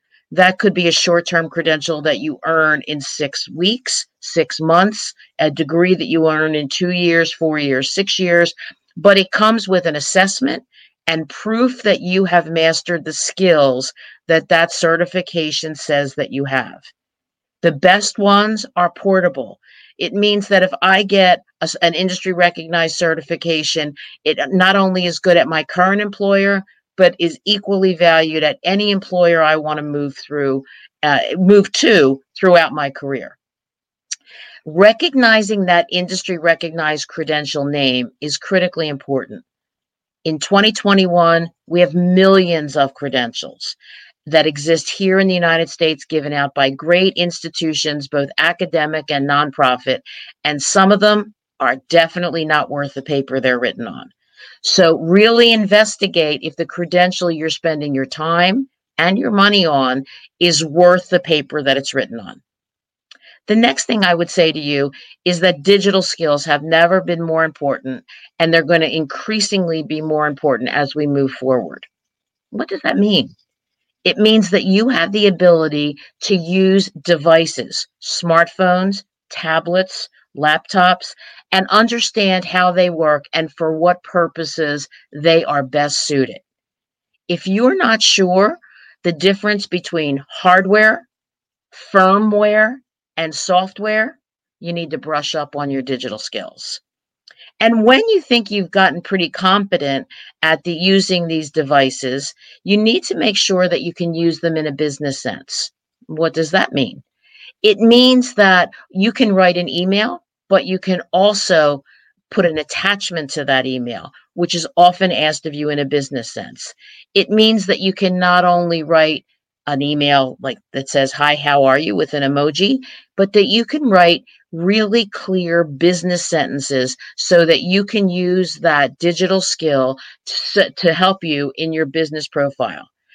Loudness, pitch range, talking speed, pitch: -15 LUFS, 150-190 Hz, 155 wpm, 170 Hz